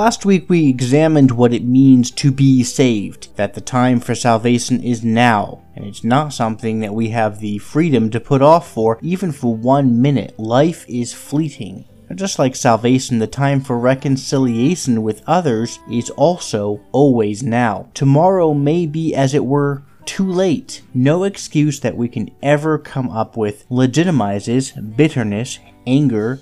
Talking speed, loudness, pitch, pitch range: 160 wpm, -16 LUFS, 125 Hz, 115-145 Hz